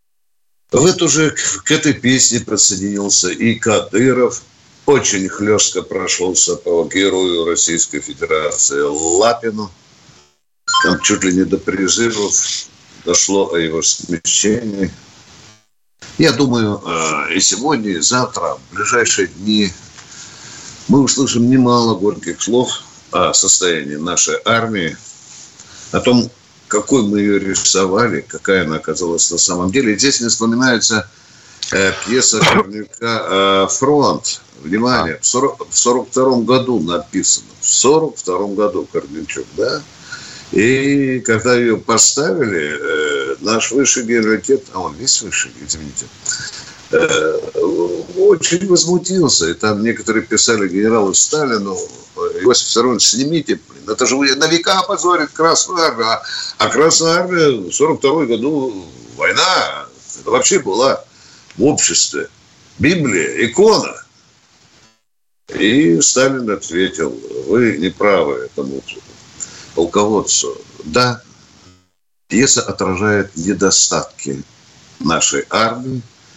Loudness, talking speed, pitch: -14 LUFS, 105 wpm, 120 Hz